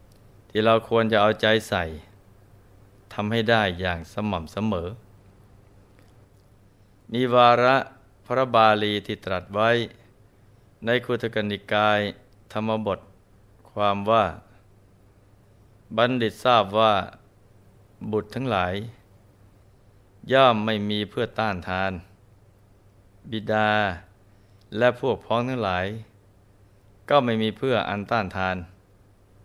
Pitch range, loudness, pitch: 100-110 Hz, -23 LUFS, 105 Hz